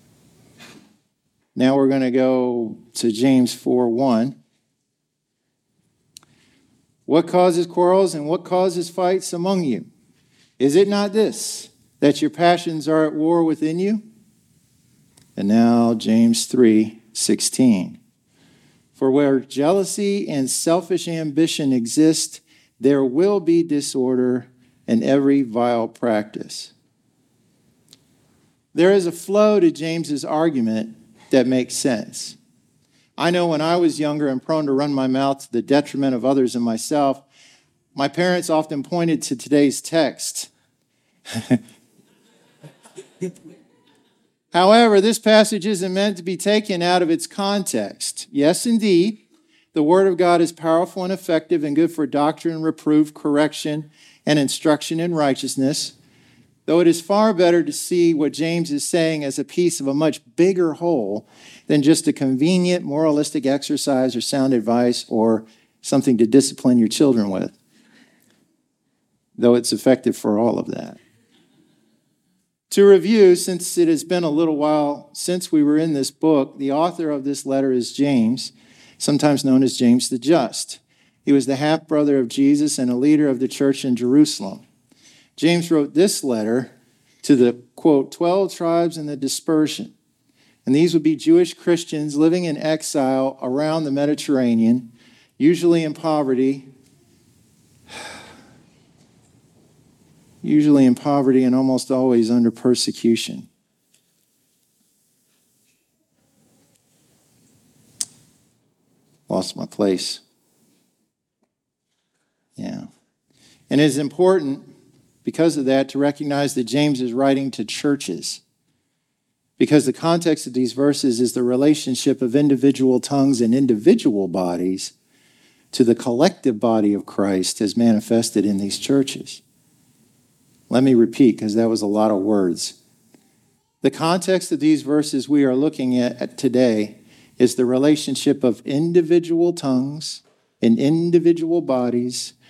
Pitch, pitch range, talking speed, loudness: 145 Hz, 130-170 Hz, 130 wpm, -19 LUFS